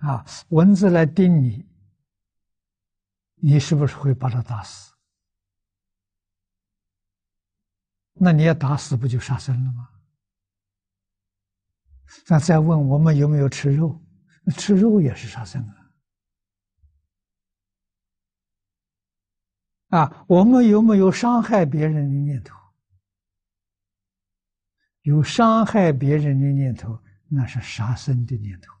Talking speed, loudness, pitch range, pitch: 150 characters per minute, -19 LUFS, 95-150 Hz, 115 Hz